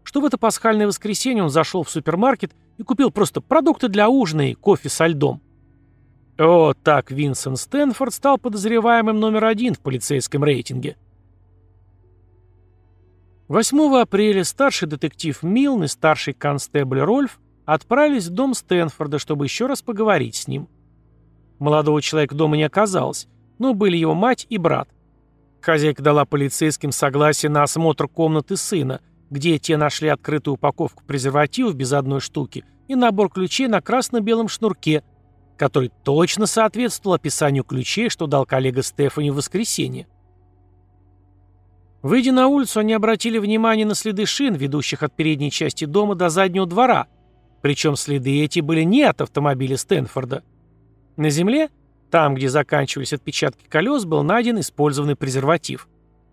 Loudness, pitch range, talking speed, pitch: -19 LUFS, 140-215 Hz, 140 wpm, 155 Hz